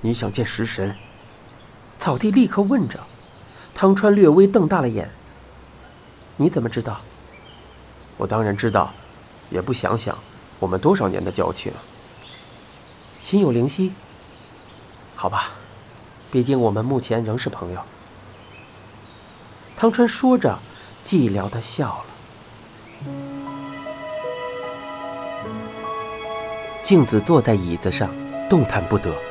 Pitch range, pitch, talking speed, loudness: 100-160 Hz, 115 Hz, 160 characters per minute, -21 LUFS